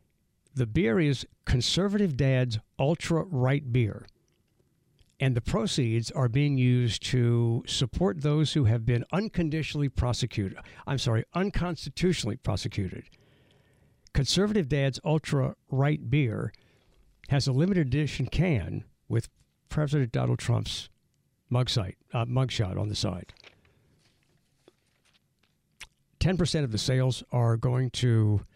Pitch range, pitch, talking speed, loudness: 115-150 Hz, 130 Hz, 110 wpm, -28 LUFS